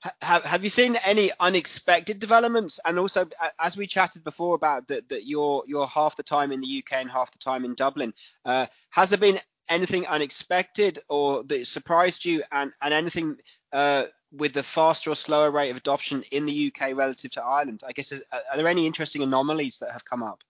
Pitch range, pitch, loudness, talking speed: 140-180 Hz, 155 Hz, -25 LUFS, 200 wpm